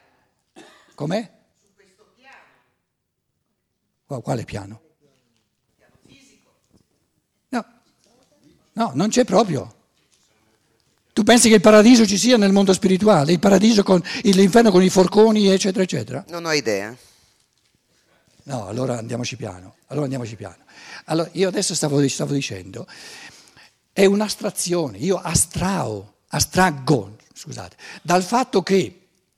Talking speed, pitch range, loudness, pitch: 115 wpm, 130-200 Hz, -18 LUFS, 180 Hz